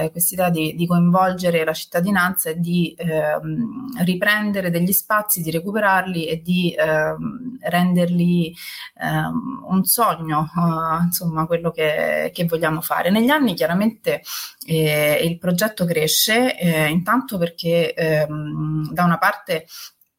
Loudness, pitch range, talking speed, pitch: -19 LUFS, 160-190 Hz, 125 wpm, 175 Hz